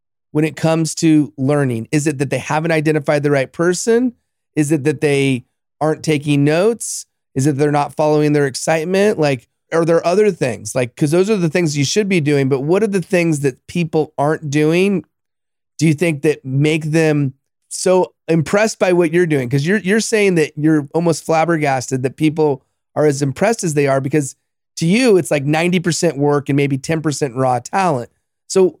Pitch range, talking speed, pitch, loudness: 140-170 Hz, 195 wpm, 155 Hz, -16 LUFS